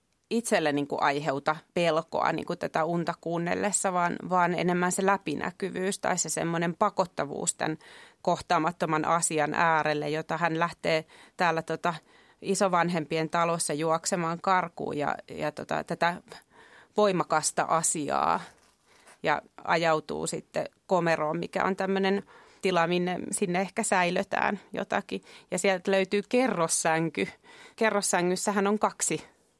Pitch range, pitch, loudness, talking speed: 165-195 Hz, 175 Hz, -28 LUFS, 120 wpm